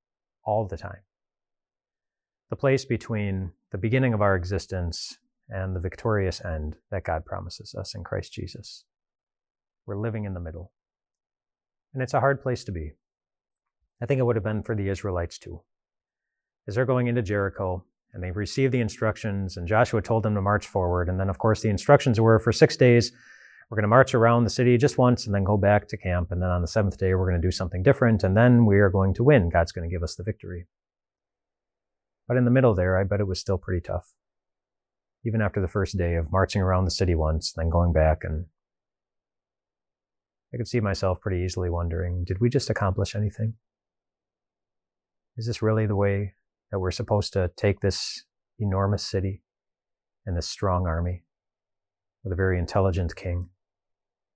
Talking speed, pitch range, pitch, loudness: 190 wpm, 90-110 Hz, 100 Hz, -25 LUFS